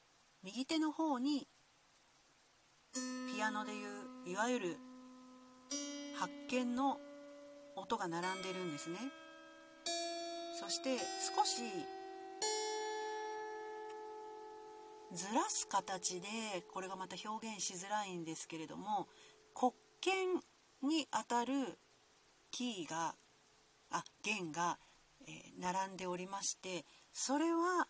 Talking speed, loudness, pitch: 175 characters per minute, -40 LUFS, 260 Hz